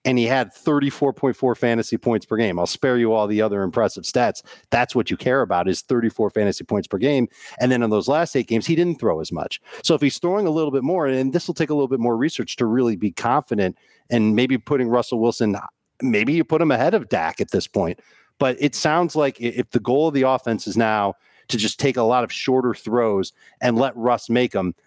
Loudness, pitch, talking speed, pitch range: -21 LUFS, 125 Hz, 240 wpm, 115-140 Hz